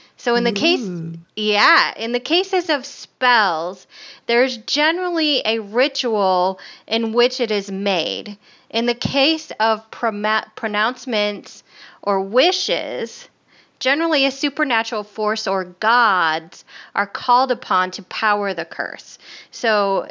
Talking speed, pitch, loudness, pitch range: 120 wpm, 225 Hz, -19 LUFS, 205-265 Hz